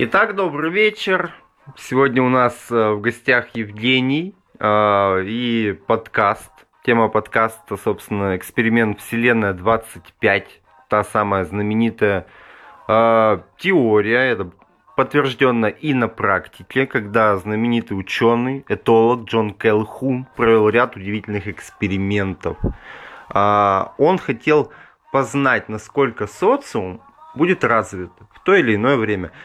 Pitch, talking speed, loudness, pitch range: 115 Hz, 105 wpm, -18 LUFS, 105-130 Hz